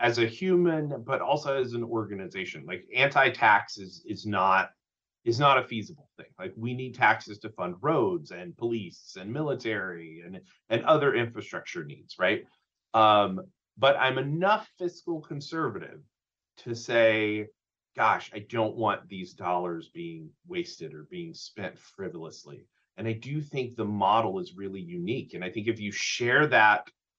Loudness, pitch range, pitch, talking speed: -27 LUFS, 105-160 Hz, 115 Hz, 160 wpm